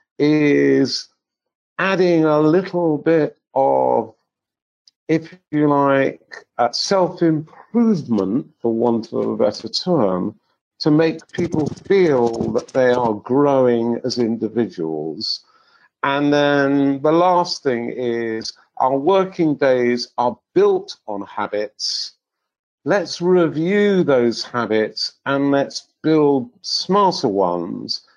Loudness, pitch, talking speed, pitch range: -18 LUFS, 140 Hz, 105 wpm, 120-170 Hz